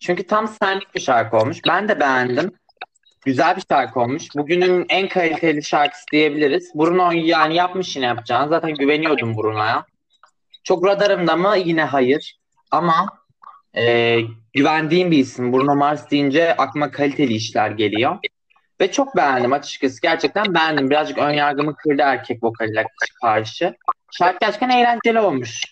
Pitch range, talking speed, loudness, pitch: 135-180 Hz, 140 wpm, -18 LUFS, 150 Hz